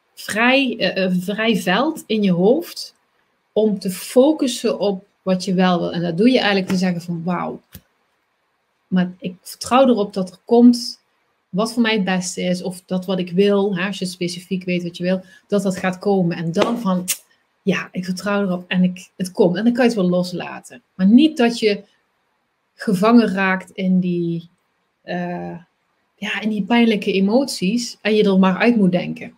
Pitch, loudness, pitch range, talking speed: 195 Hz, -18 LUFS, 180-220 Hz, 190 wpm